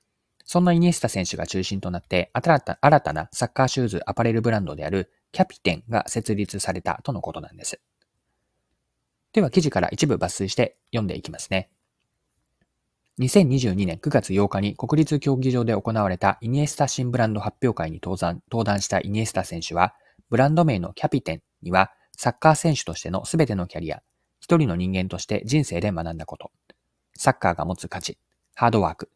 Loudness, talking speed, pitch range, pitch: -23 LUFS, 370 characters per minute, 90-130 Hz, 105 Hz